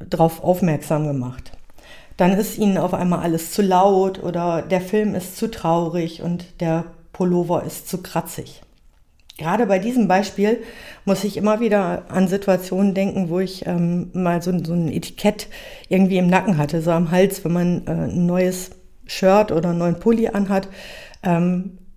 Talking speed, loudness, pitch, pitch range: 165 wpm, -20 LUFS, 180 Hz, 170-195 Hz